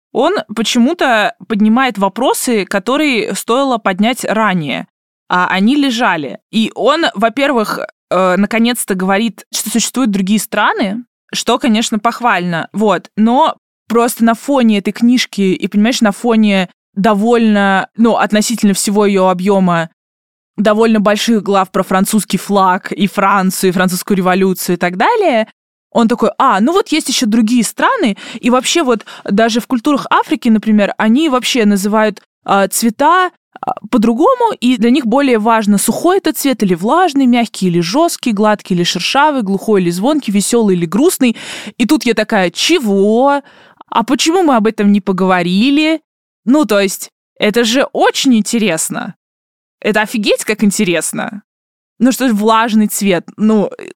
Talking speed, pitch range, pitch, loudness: 145 wpm, 200-250 Hz, 220 Hz, -12 LUFS